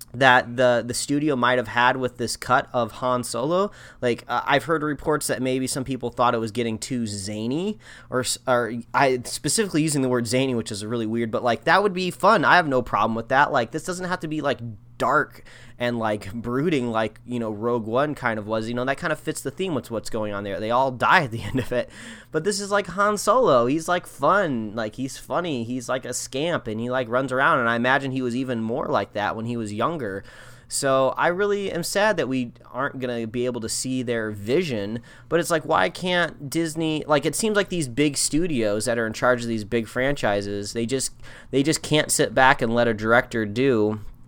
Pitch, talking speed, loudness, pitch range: 125 Hz, 235 wpm, -23 LUFS, 115-145 Hz